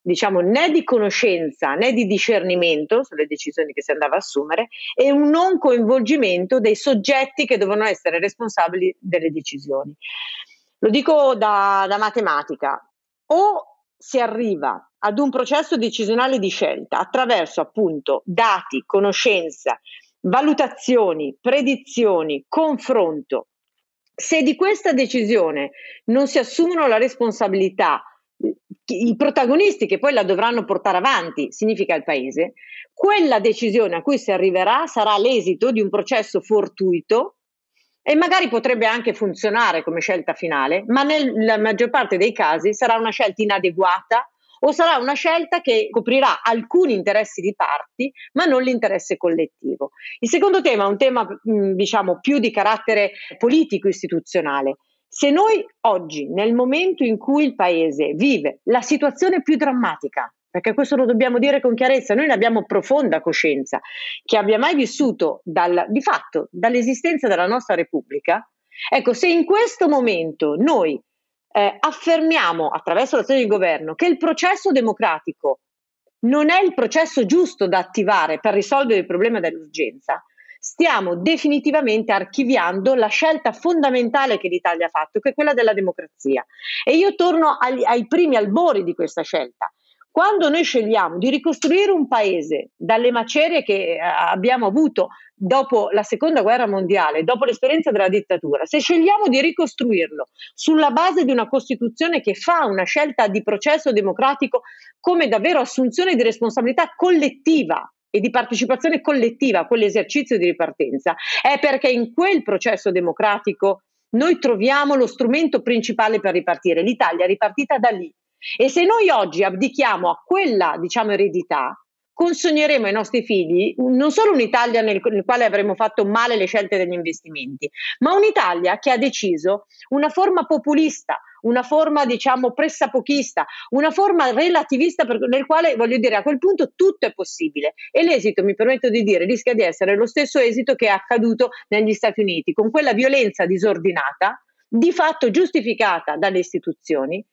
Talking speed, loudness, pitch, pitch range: 145 wpm, -18 LUFS, 245 Hz, 200-300 Hz